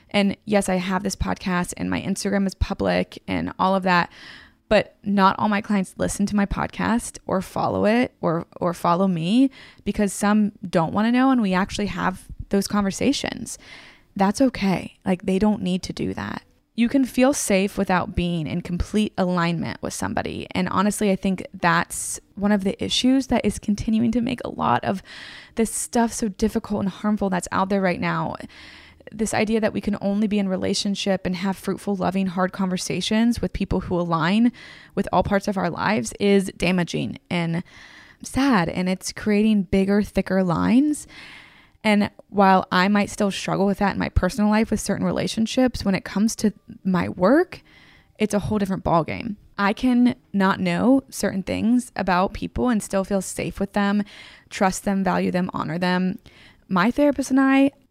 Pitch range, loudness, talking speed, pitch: 185-220 Hz, -22 LUFS, 180 wpm, 200 Hz